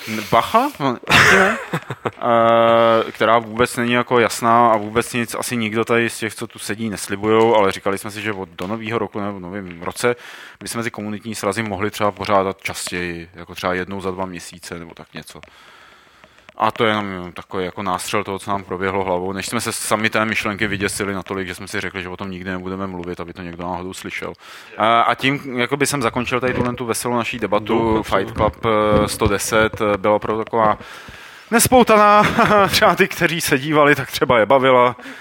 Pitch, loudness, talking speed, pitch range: 110 Hz, -18 LUFS, 185 wpm, 95-120 Hz